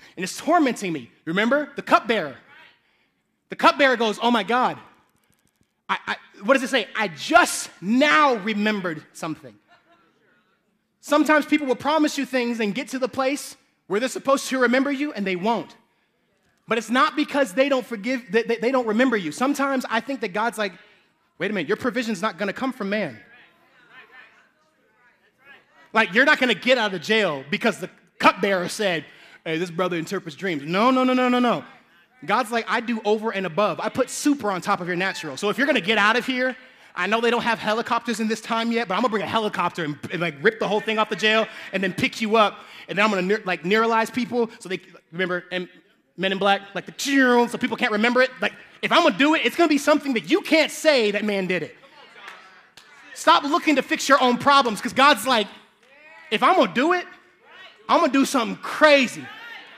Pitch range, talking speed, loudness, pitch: 205-270 Hz, 210 wpm, -21 LUFS, 230 Hz